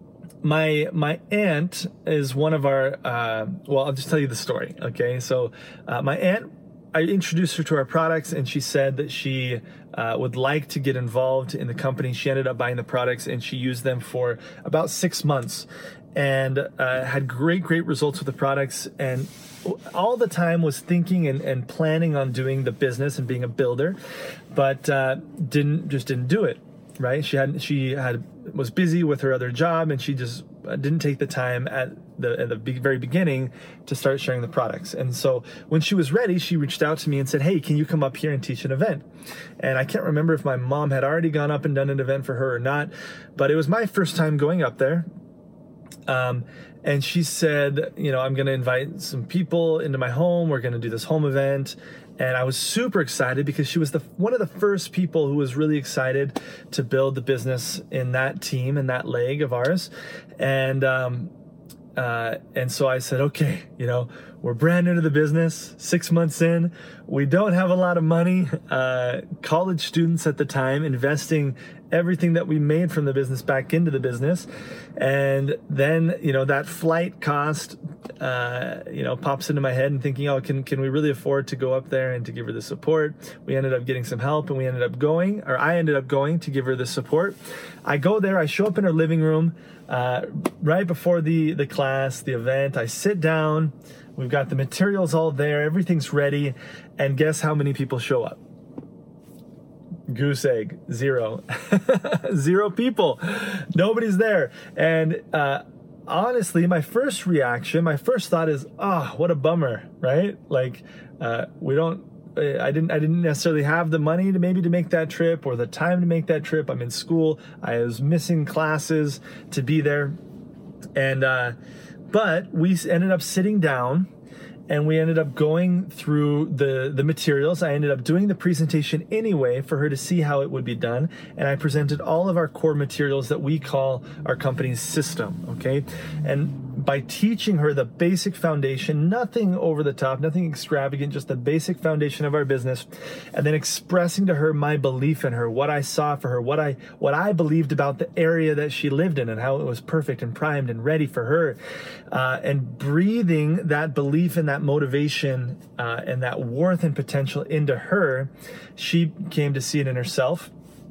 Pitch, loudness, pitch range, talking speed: 150 Hz, -23 LUFS, 135-165 Hz, 200 wpm